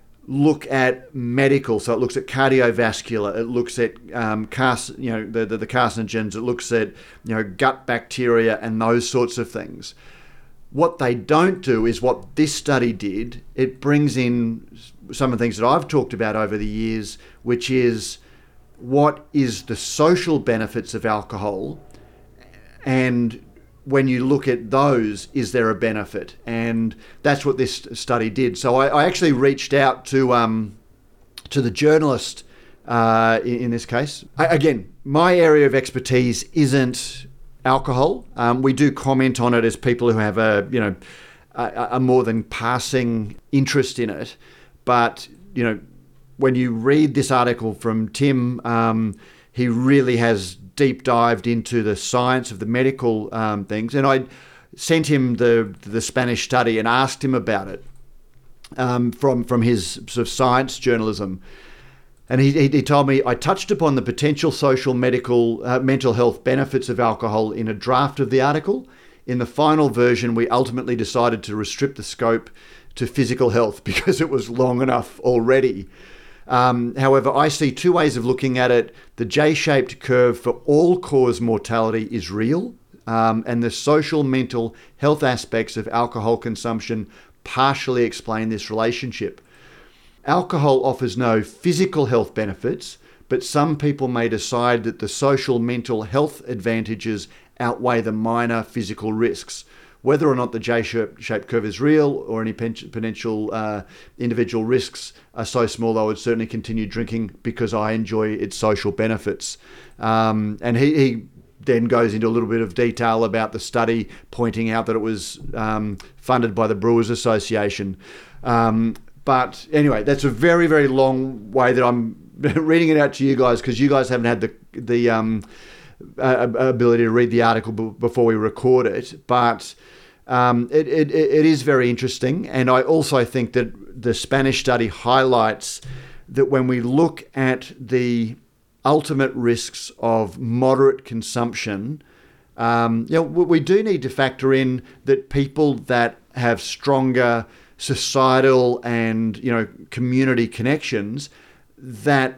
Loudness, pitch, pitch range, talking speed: -20 LUFS, 120 Hz, 115-135 Hz, 160 wpm